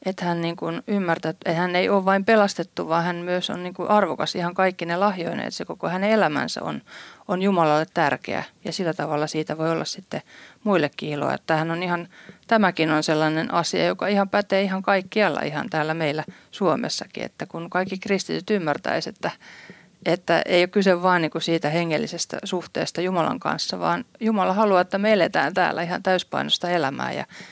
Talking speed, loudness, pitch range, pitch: 180 wpm, -23 LUFS, 165-195 Hz, 180 Hz